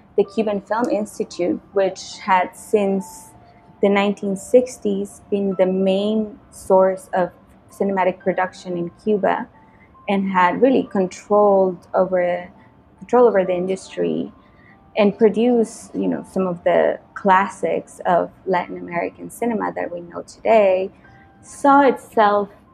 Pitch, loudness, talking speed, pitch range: 200 Hz, -19 LUFS, 120 wpm, 185-215 Hz